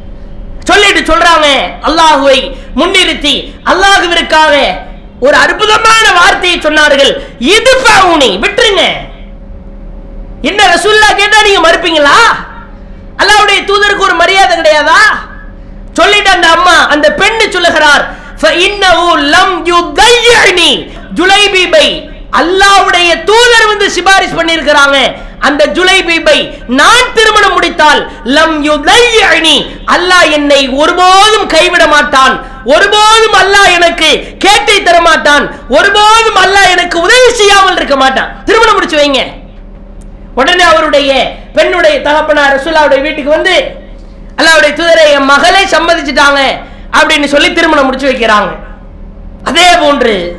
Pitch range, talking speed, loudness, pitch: 300-390 Hz, 100 wpm, -5 LUFS, 335 Hz